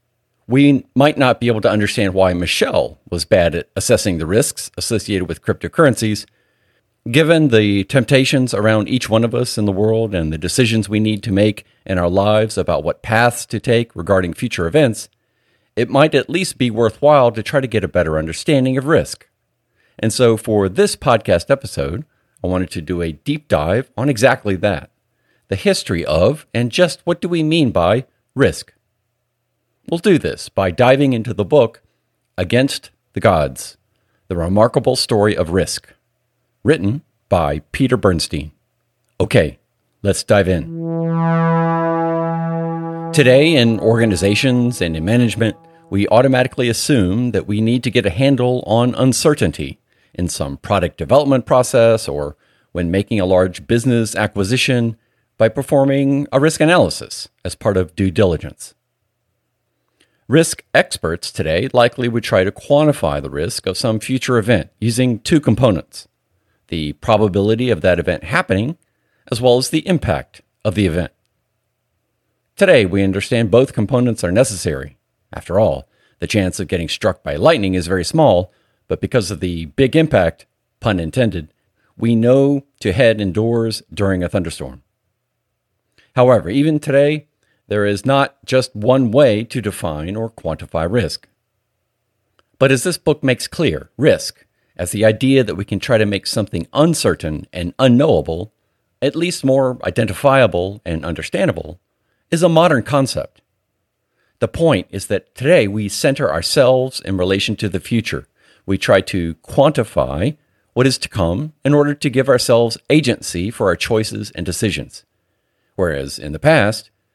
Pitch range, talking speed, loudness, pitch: 95-130 Hz, 155 wpm, -16 LUFS, 115 Hz